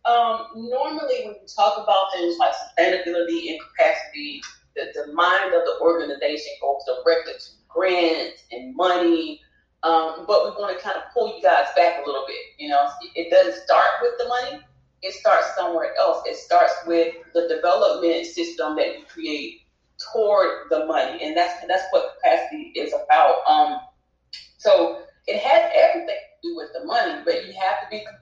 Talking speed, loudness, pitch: 180 wpm, -21 LUFS, 245 Hz